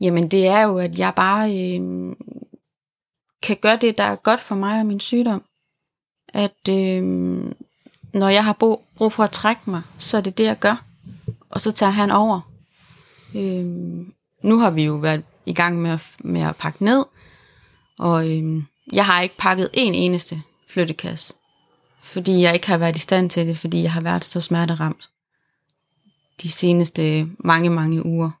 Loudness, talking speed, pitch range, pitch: -20 LUFS, 175 wpm, 160-200 Hz, 175 Hz